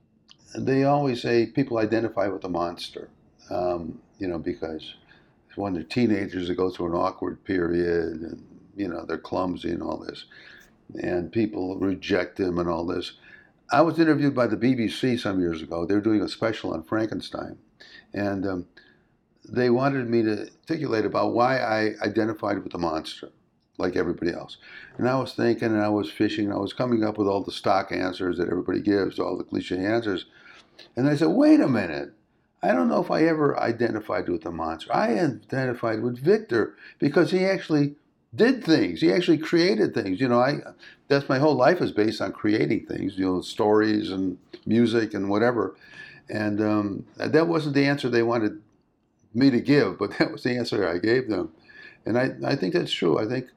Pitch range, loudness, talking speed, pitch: 100-140 Hz, -25 LUFS, 190 wpm, 115 Hz